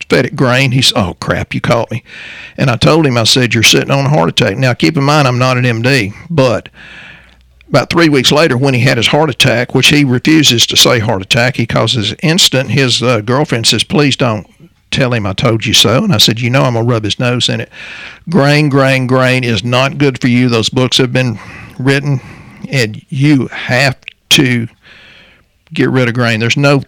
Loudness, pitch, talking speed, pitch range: -10 LUFS, 130 Hz, 215 wpm, 115-140 Hz